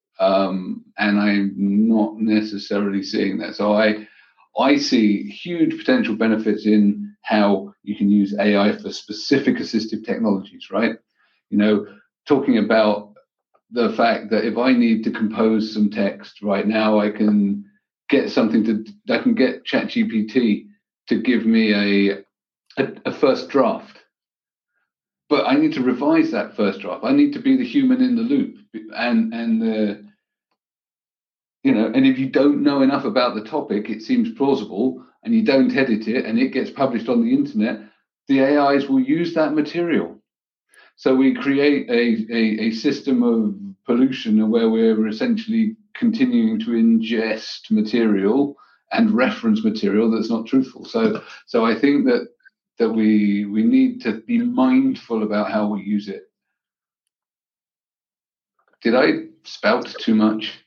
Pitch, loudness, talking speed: 140 Hz, -19 LUFS, 155 wpm